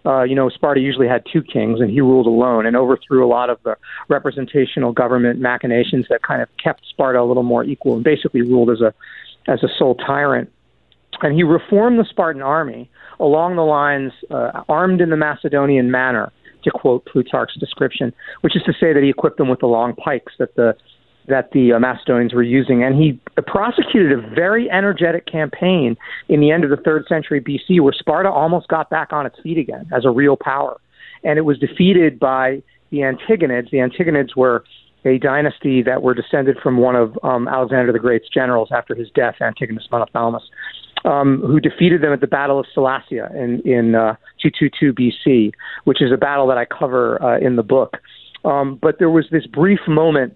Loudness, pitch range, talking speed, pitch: -16 LUFS, 125-155 Hz, 200 wpm, 135 Hz